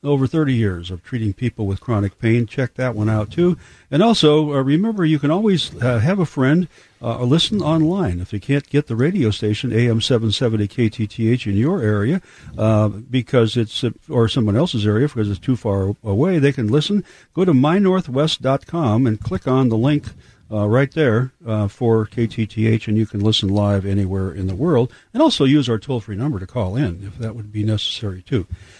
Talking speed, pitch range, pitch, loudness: 200 wpm, 105-145 Hz, 120 Hz, -19 LUFS